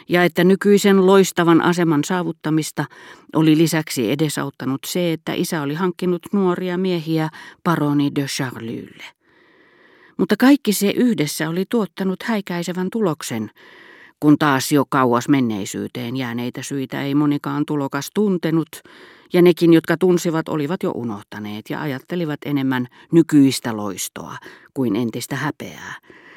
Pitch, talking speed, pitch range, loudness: 155 Hz, 120 wpm, 140-180 Hz, -19 LUFS